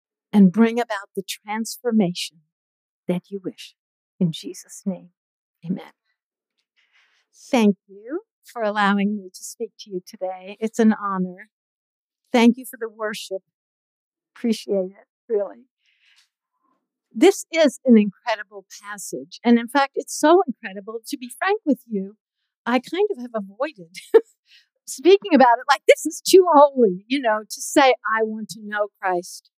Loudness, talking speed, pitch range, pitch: -20 LUFS, 145 wpm, 200-270 Hz, 220 Hz